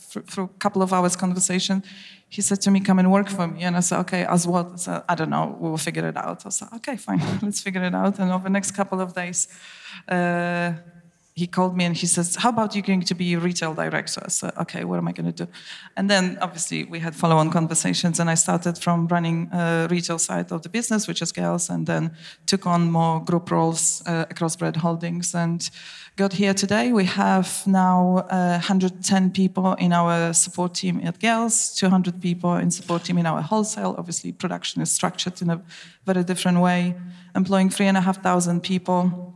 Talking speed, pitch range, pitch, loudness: 220 wpm, 170-190 Hz, 180 Hz, -22 LUFS